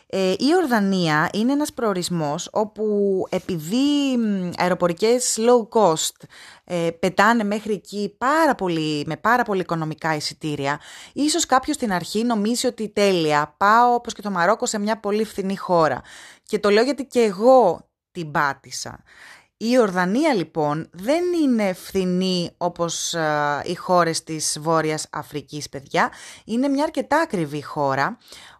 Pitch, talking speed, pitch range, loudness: 195 Hz, 140 wpm, 165-235 Hz, -21 LUFS